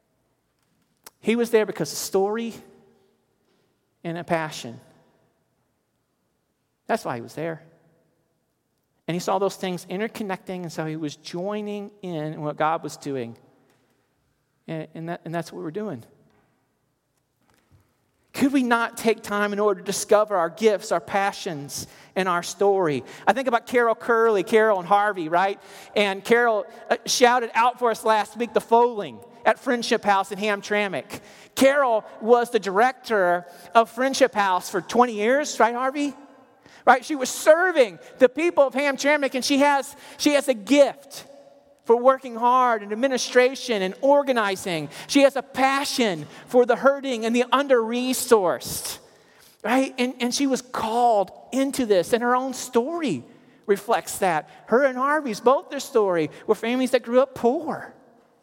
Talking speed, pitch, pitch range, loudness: 155 wpm, 225 Hz, 185-255 Hz, -22 LUFS